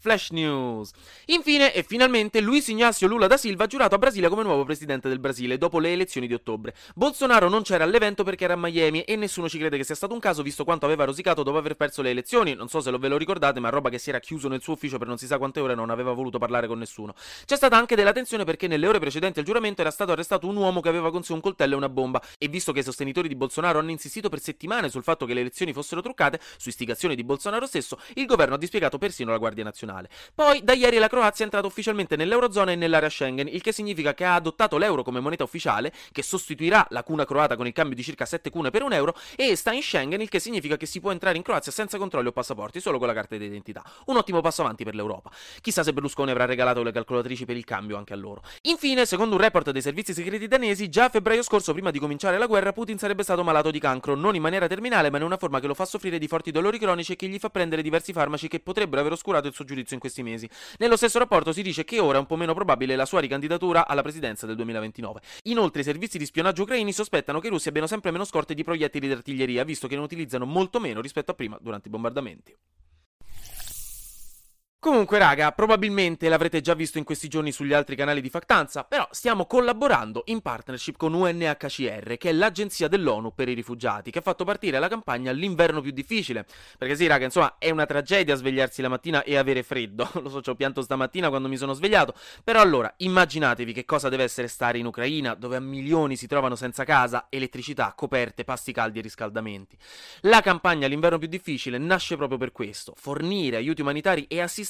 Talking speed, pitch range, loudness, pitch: 235 wpm, 130-190 Hz, -24 LUFS, 155 Hz